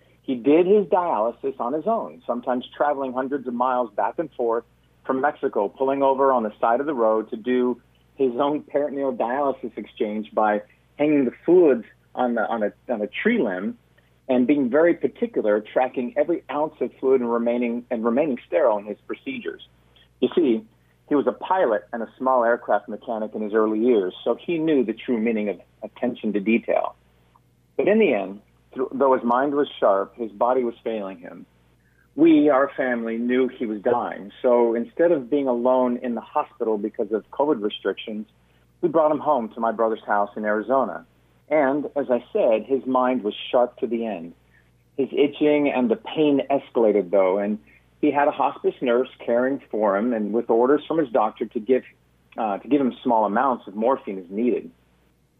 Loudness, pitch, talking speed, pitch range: -23 LUFS, 120 Hz, 190 wpm, 110-140 Hz